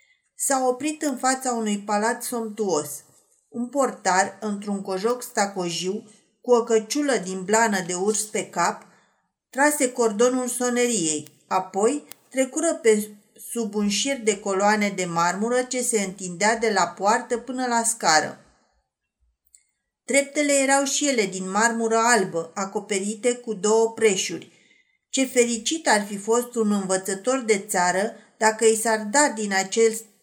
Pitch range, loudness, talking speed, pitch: 200-245 Hz, -23 LUFS, 135 wpm, 225 Hz